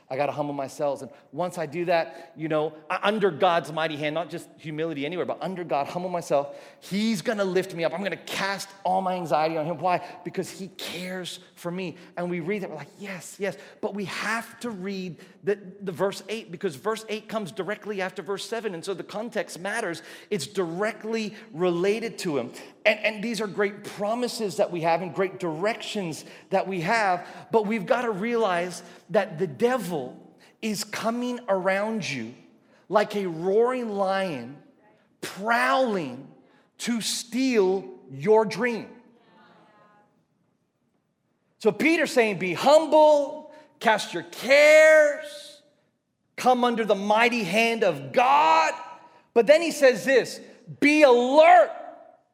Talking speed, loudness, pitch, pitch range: 155 wpm, -24 LUFS, 200 Hz, 175-225 Hz